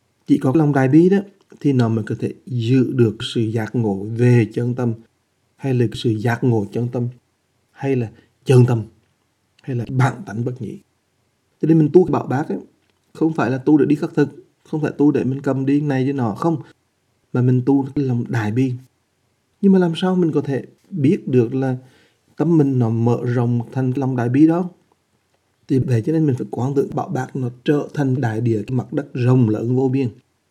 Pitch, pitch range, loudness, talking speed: 130 Hz, 120-145 Hz, -19 LUFS, 220 wpm